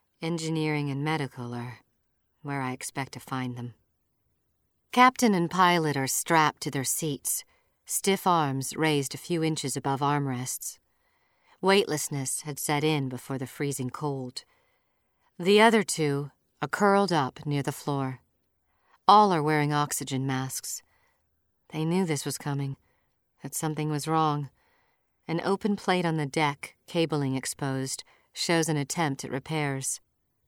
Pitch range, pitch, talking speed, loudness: 135-165 Hz, 145 Hz, 140 wpm, -27 LUFS